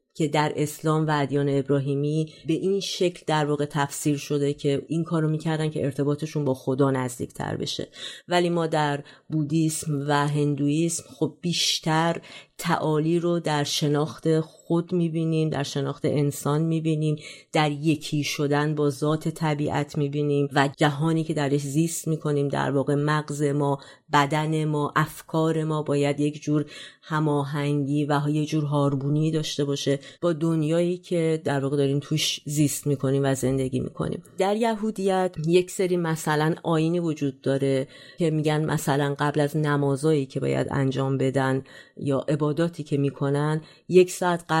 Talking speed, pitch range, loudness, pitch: 150 wpm, 145-160 Hz, -25 LUFS, 150 Hz